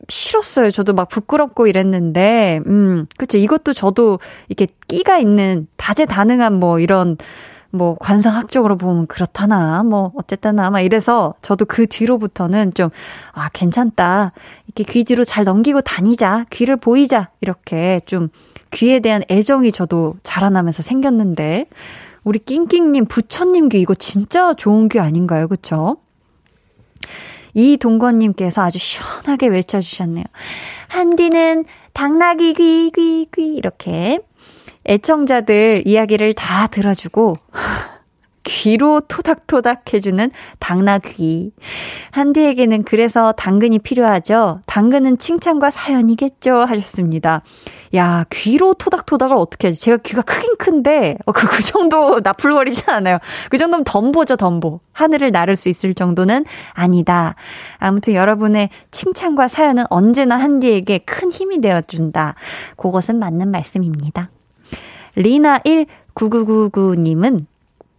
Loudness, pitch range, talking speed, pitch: -14 LUFS, 185-270 Hz, 285 characters per minute, 215 Hz